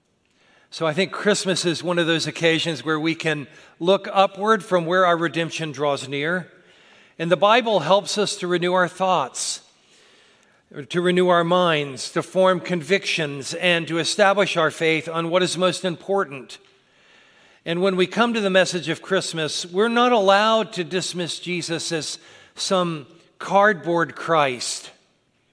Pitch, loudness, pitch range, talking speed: 175 Hz, -21 LUFS, 165-190 Hz, 155 wpm